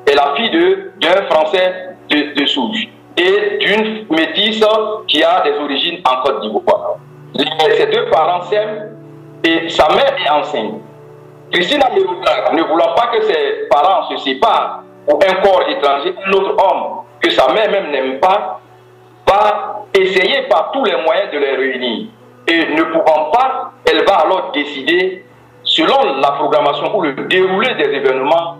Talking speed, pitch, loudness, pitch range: 155 wpm, 190 Hz, -13 LUFS, 155-260 Hz